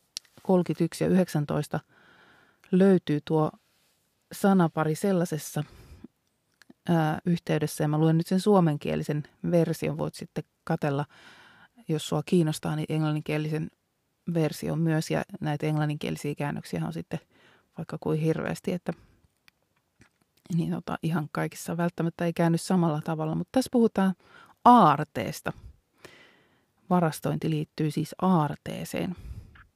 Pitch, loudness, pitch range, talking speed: 160 Hz, -27 LUFS, 150-175 Hz, 105 wpm